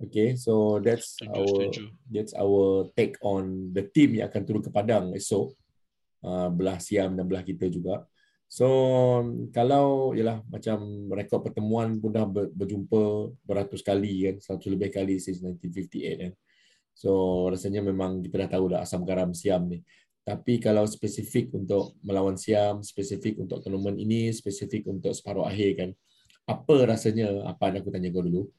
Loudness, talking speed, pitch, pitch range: -27 LUFS, 160 wpm, 100 Hz, 95-110 Hz